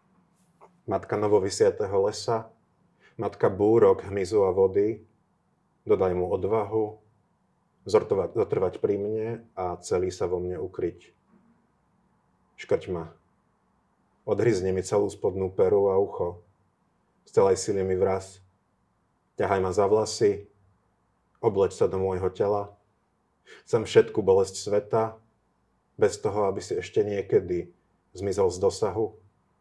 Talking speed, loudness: 115 wpm, -26 LUFS